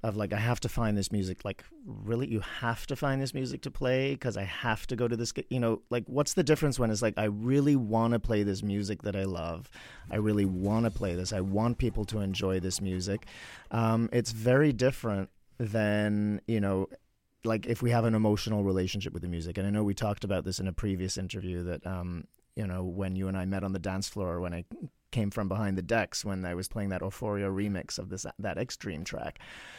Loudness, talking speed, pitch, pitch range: -31 LUFS, 235 wpm, 105 Hz, 95-115 Hz